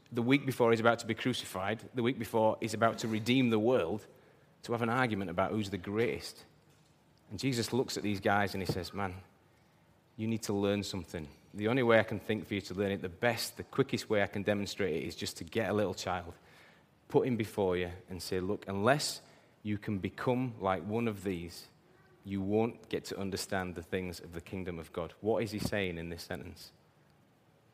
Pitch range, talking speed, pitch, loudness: 95-115 Hz, 220 wpm, 105 Hz, -34 LUFS